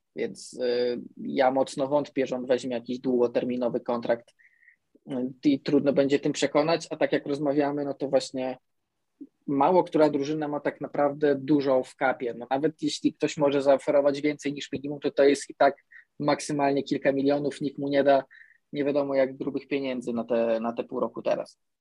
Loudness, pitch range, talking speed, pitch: -26 LUFS, 130-145 Hz, 180 wpm, 140 Hz